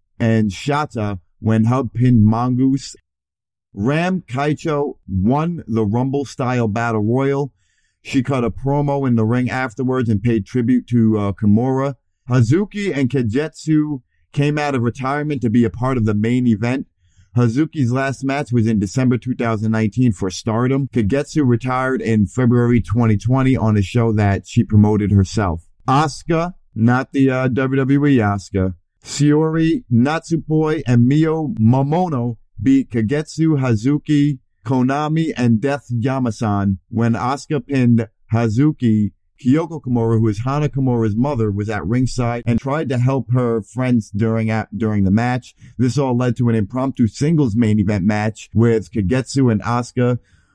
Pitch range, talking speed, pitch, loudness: 110-135 Hz, 145 wpm, 120 Hz, -18 LUFS